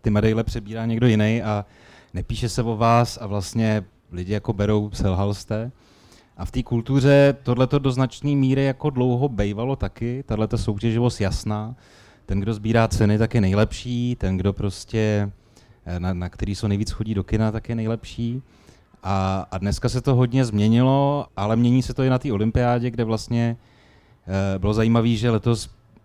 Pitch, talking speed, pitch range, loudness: 115 Hz, 170 wpm, 100-120 Hz, -22 LUFS